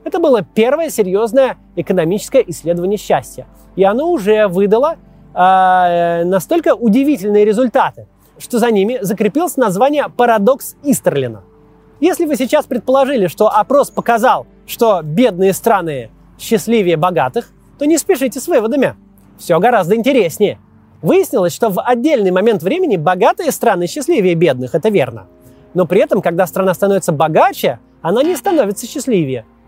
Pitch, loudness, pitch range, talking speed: 215 Hz, -14 LUFS, 185-270 Hz, 130 wpm